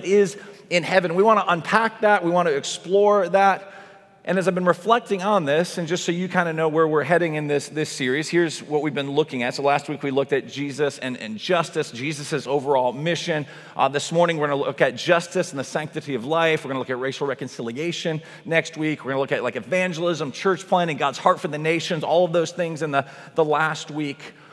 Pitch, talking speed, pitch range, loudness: 165 Hz, 235 wpm, 145-180 Hz, -22 LUFS